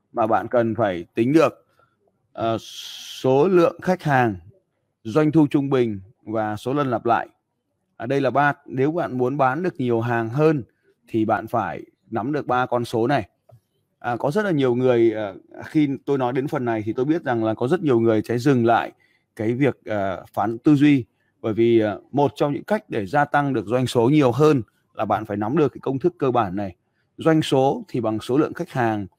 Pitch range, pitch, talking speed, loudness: 115-145 Hz, 125 Hz, 220 wpm, -21 LUFS